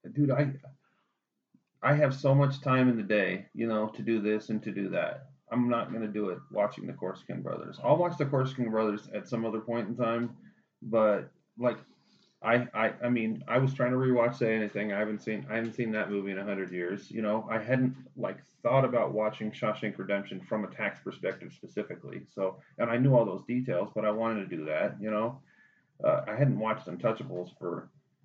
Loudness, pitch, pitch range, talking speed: -31 LUFS, 115 Hz, 105-130 Hz, 210 wpm